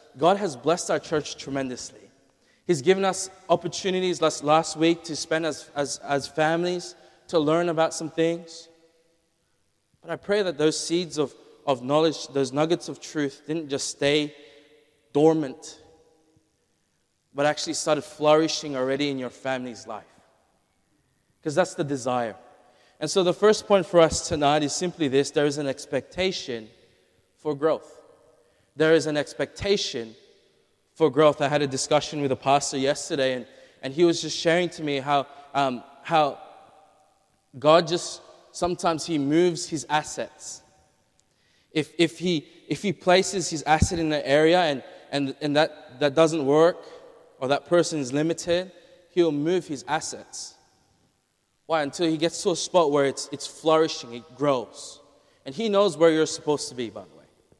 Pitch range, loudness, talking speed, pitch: 145-170 Hz, -24 LUFS, 160 wpm, 155 Hz